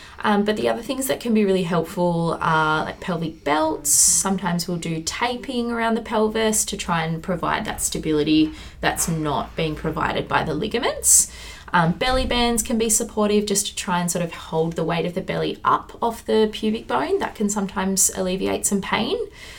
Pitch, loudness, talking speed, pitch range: 190 Hz, -21 LUFS, 195 wpm, 165-220 Hz